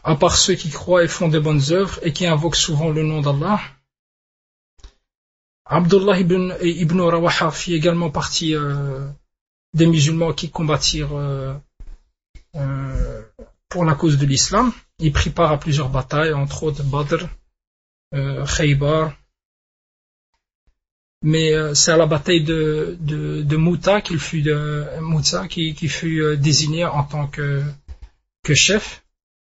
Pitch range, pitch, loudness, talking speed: 145-170 Hz, 155 Hz, -18 LUFS, 140 wpm